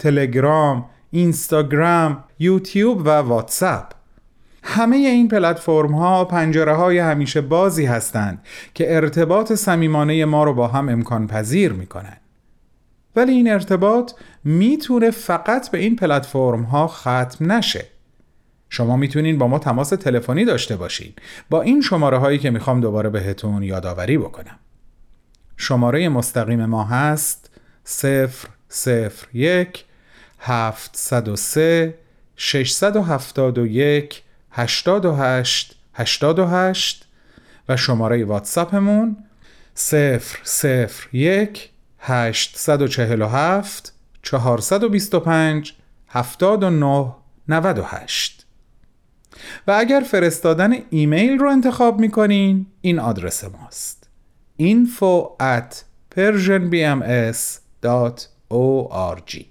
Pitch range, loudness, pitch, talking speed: 125-185 Hz, -18 LUFS, 150 Hz, 90 wpm